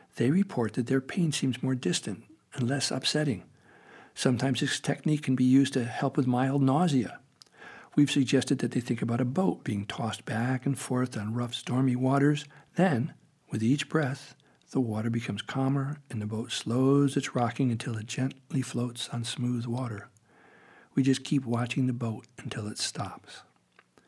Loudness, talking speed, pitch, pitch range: -29 LUFS, 170 wpm, 130 Hz, 120-140 Hz